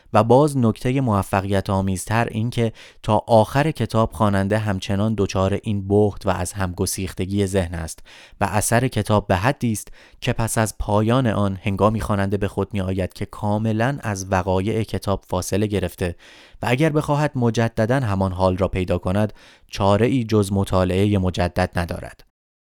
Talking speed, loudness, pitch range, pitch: 155 wpm, -21 LUFS, 95-110 Hz, 100 Hz